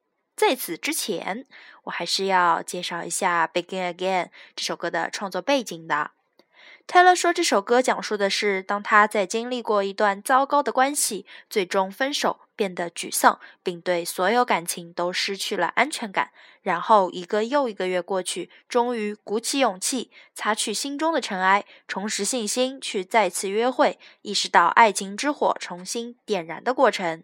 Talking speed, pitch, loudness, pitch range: 265 characters per minute, 210 Hz, -23 LUFS, 185-250 Hz